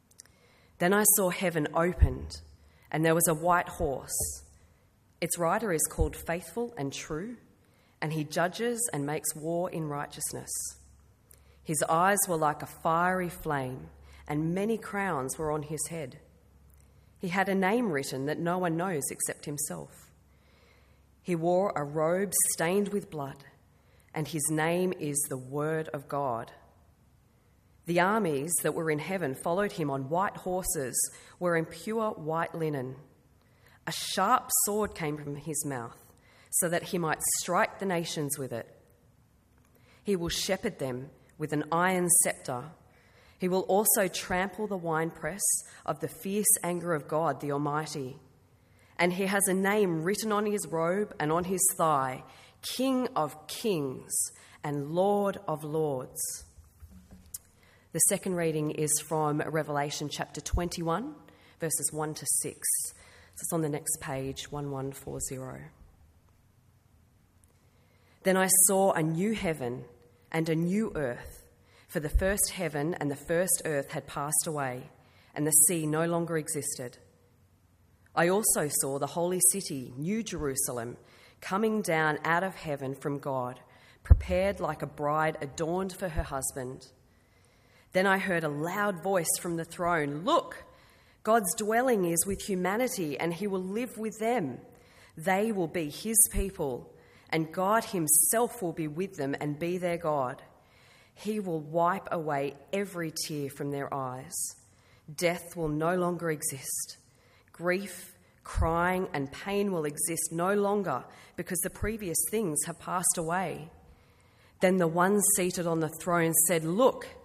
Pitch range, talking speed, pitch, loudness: 135-185 Hz, 145 wpm, 160 Hz, -29 LUFS